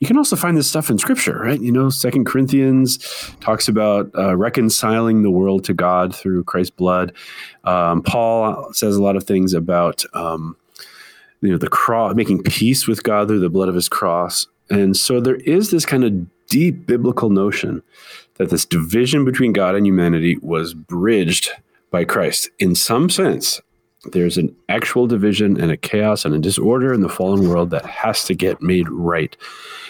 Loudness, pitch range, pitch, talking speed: -17 LUFS, 90-125 Hz, 100 Hz, 185 wpm